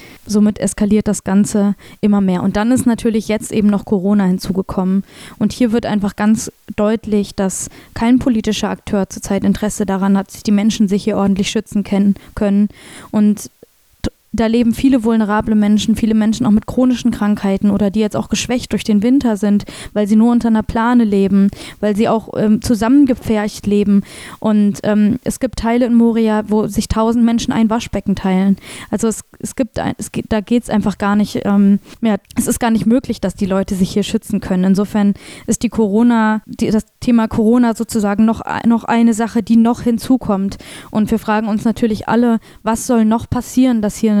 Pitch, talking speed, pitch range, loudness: 215 Hz, 190 wpm, 205-230 Hz, -15 LUFS